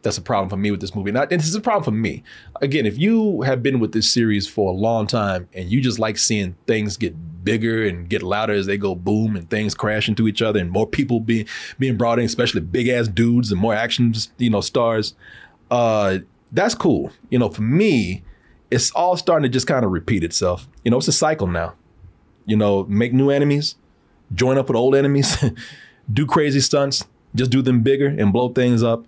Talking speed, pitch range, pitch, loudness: 225 wpm, 100-130 Hz, 115 Hz, -19 LUFS